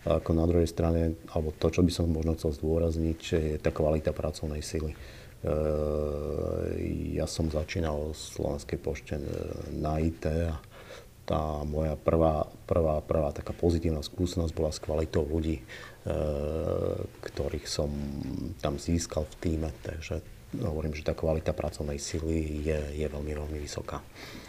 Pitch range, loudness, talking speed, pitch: 75-85 Hz, -31 LUFS, 140 wpm, 80 Hz